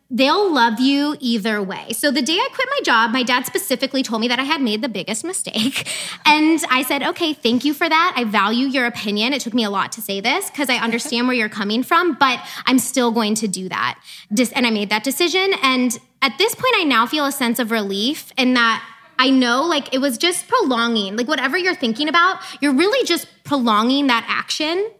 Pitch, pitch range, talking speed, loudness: 260 Hz, 230-310 Hz, 225 wpm, -18 LUFS